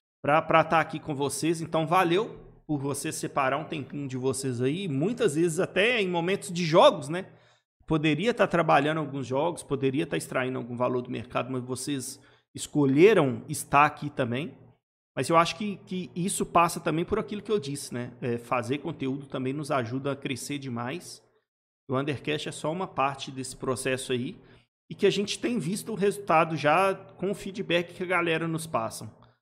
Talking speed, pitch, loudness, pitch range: 185 wpm, 150 Hz, -27 LUFS, 135-175 Hz